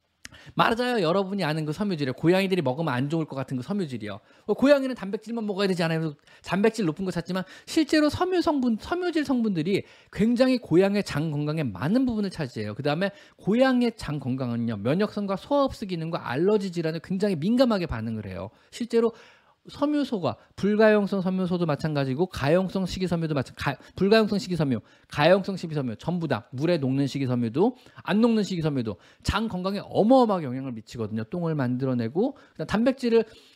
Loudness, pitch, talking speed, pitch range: -25 LUFS, 185 Hz, 410 characters per minute, 145-220 Hz